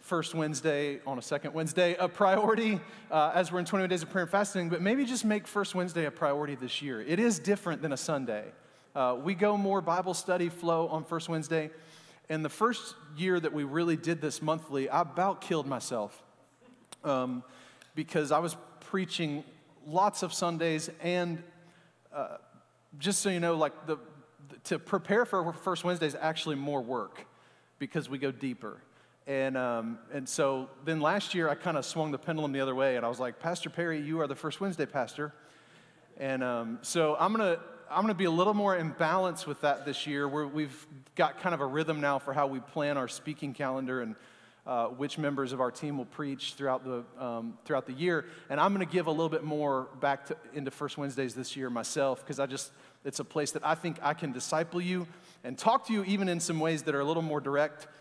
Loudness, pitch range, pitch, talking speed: -32 LUFS, 140-175 Hz, 155 Hz, 215 wpm